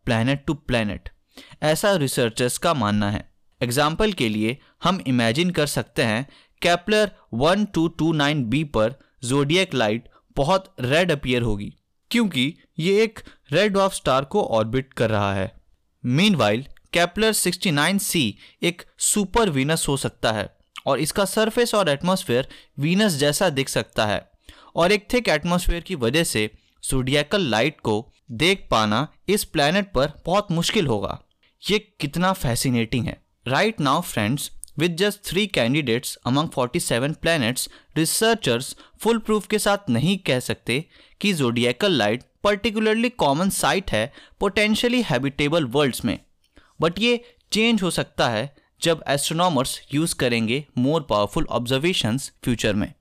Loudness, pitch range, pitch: -22 LUFS, 125-190 Hz, 150 Hz